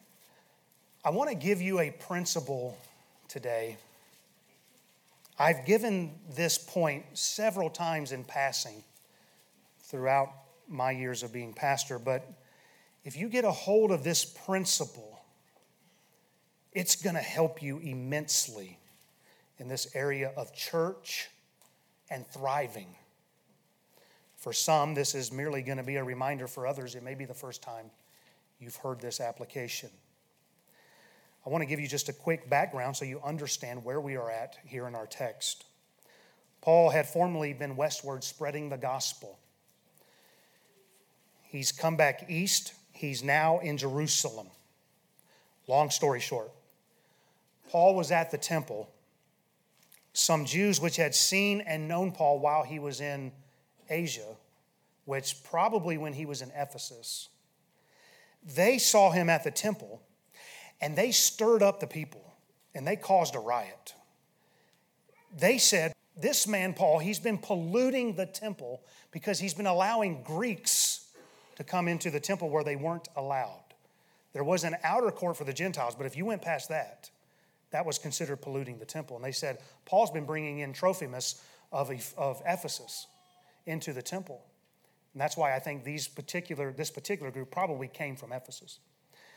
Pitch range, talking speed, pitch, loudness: 135-175 Hz, 145 wpm, 150 Hz, -31 LUFS